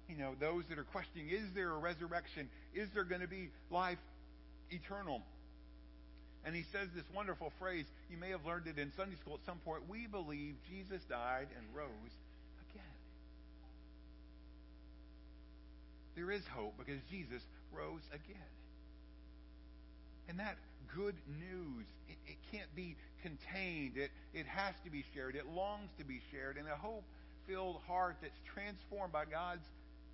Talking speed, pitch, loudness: 150 wpm, 145 Hz, -46 LUFS